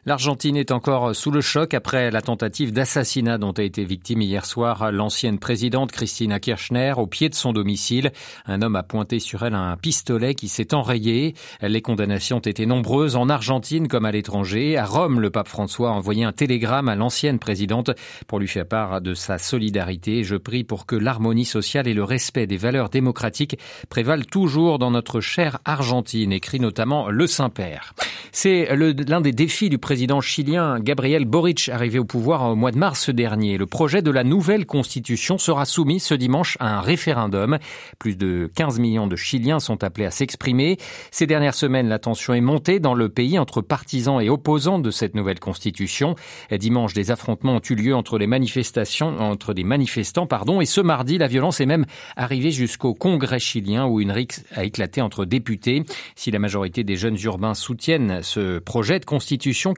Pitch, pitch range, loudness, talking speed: 125 Hz, 110-145 Hz, -21 LUFS, 190 wpm